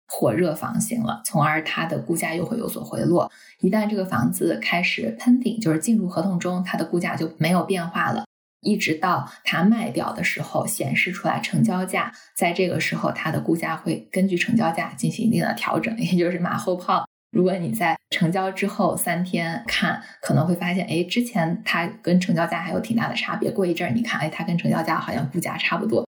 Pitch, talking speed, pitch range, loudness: 185 Hz, 320 characters per minute, 175-205 Hz, -23 LUFS